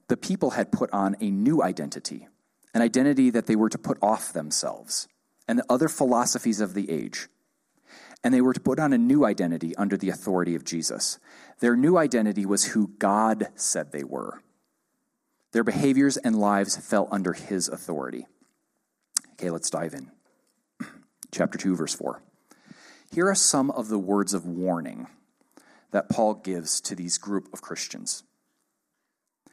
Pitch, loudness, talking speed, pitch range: 110 Hz, -25 LUFS, 160 wpm, 95-155 Hz